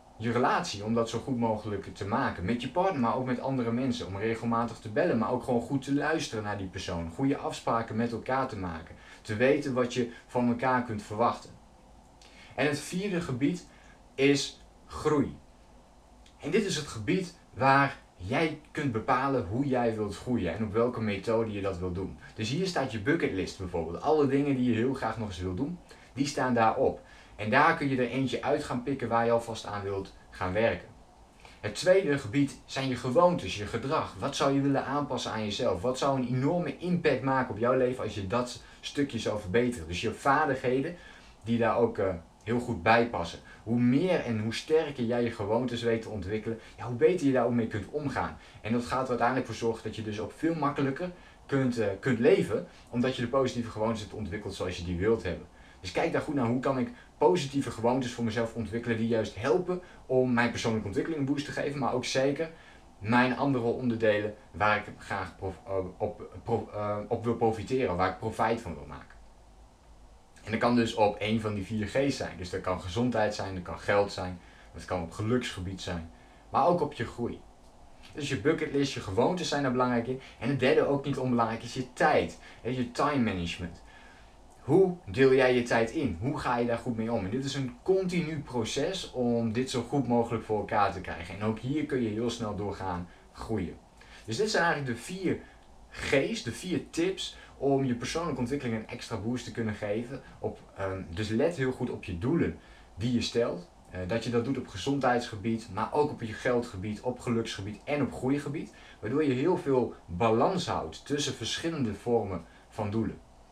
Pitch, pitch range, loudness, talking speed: 115 Hz, 105-135 Hz, -30 LUFS, 200 wpm